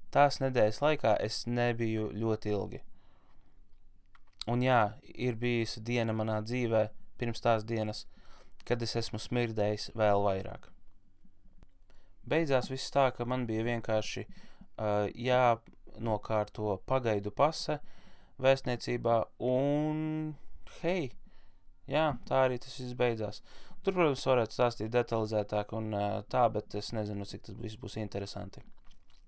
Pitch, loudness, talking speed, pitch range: 115 Hz, -32 LUFS, 115 wpm, 105-125 Hz